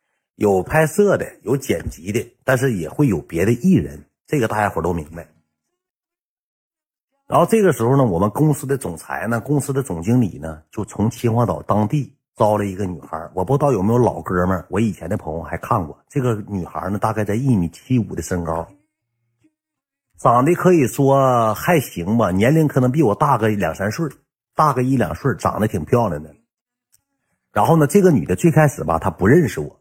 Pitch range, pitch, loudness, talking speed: 95-145 Hz, 115 Hz, -18 LUFS, 285 characters per minute